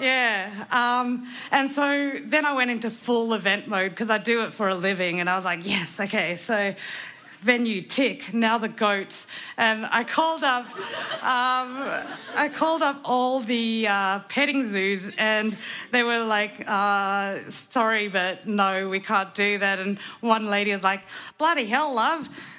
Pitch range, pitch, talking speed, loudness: 200-250 Hz, 225 Hz, 165 wpm, -24 LUFS